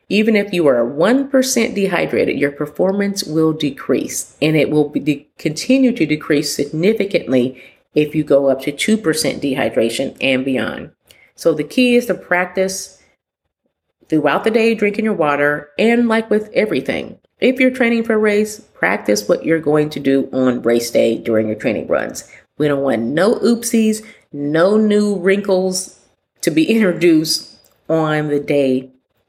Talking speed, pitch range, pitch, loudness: 160 wpm, 145-215 Hz, 160 Hz, -16 LUFS